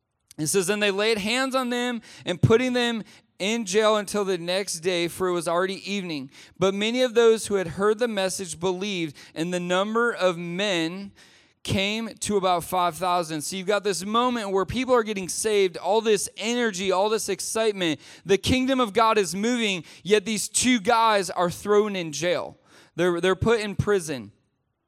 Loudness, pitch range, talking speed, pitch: -24 LUFS, 180-220 Hz, 185 wpm, 195 Hz